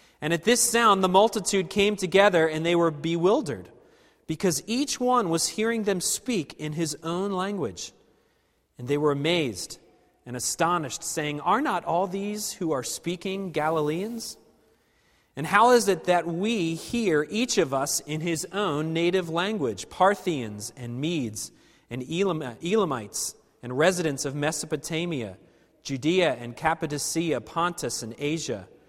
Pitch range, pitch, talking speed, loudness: 150-195 Hz, 165 Hz, 145 wpm, -26 LUFS